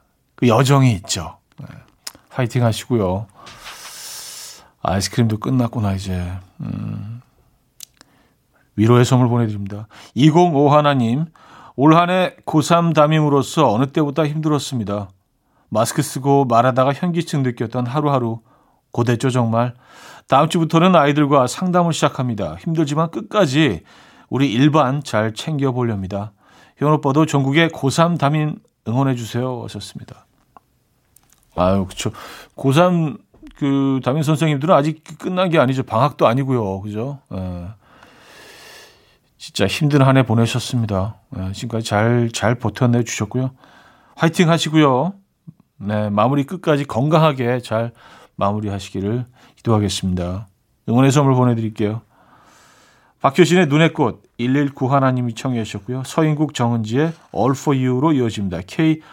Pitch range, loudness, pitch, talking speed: 110-155 Hz, -18 LUFS, 130 Hz, 290 characters per minute